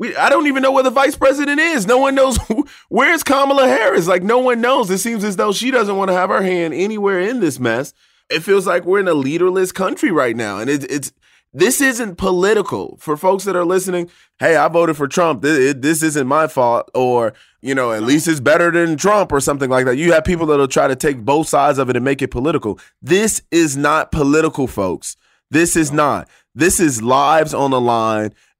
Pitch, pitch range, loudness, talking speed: 170 Hz, 140-220 Hz, -15 LUFS, 225 wpm